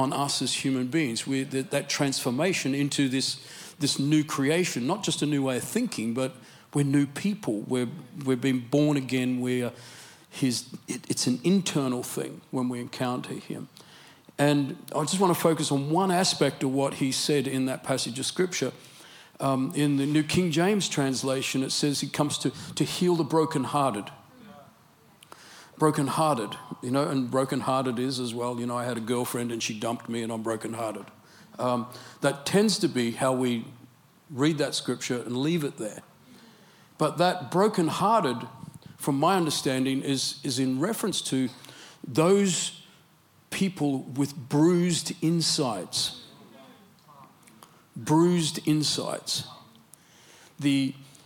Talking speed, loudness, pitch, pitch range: 150 wpm, -27 LUFS, 140 Hz, 130-160 Hz